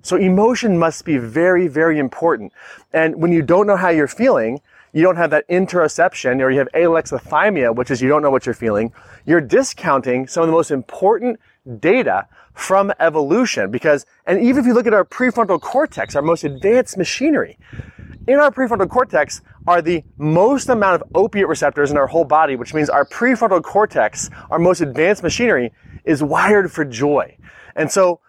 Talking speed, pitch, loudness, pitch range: 180 wpm, 165 Hz, -16 LUFS, 145-205 Hz